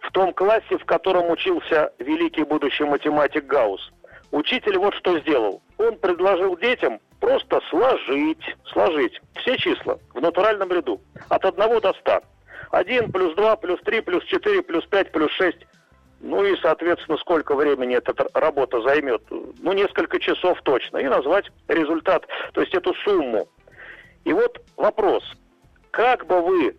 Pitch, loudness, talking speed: 315 Hz, -21 LUFS, 145 wpm